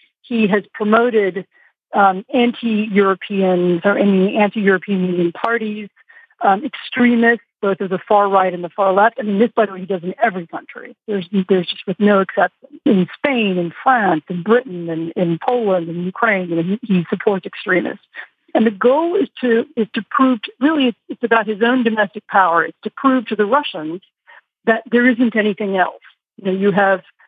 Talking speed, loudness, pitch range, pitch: 195 wpm, -17 LUFS, 190-235 Hz, 210 Hz